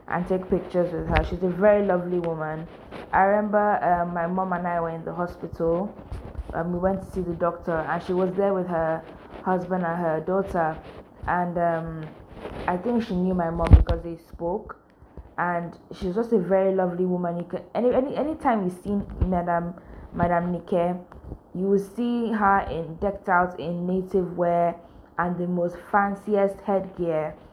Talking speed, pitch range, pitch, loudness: 180 wpm, 170-195 Hz, 180 Hz, -25 LUFS